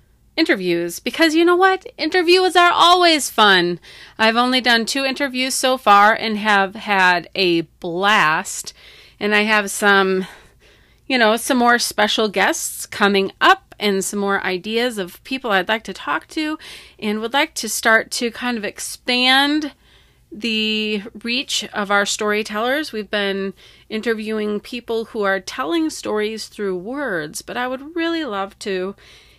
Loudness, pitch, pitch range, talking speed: -18 LUFS, 220 Hz, 200-265 Hz, 150 wpm